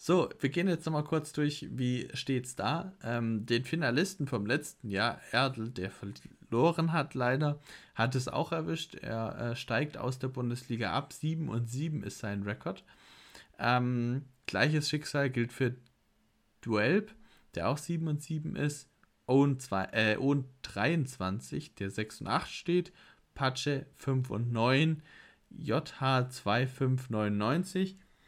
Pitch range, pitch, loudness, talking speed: 120-155 Hz, 130 Hz, -32 LUFS, 140 wpm